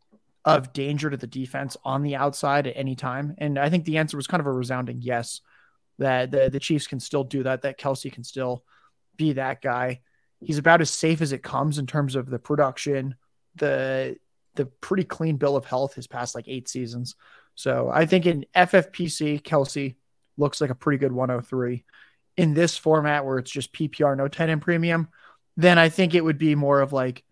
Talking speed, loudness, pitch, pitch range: 205 wpm, -24 LUFS, 140 Hz, 130-155 Hz